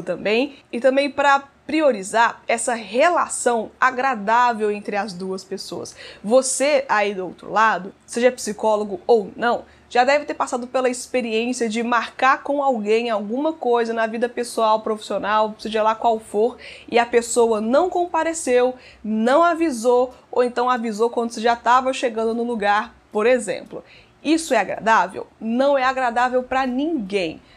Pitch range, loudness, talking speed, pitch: 220-260 Hz, -20 LUFS, 150 wpm, 240 Hz